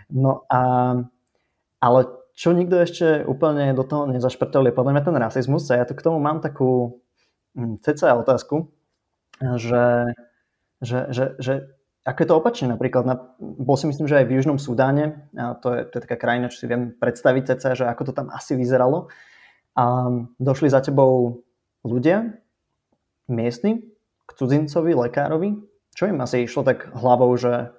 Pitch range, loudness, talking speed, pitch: 125-150 Hz, -21 LUFS, 160 wpm, 130 Hz